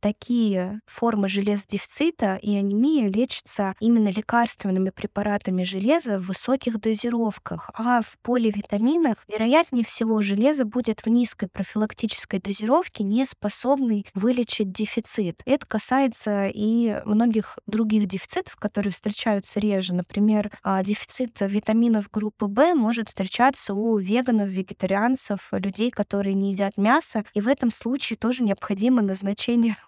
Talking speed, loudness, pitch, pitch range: 120 wpm, -23 LUFS, 215 Hz, 200-240 Hz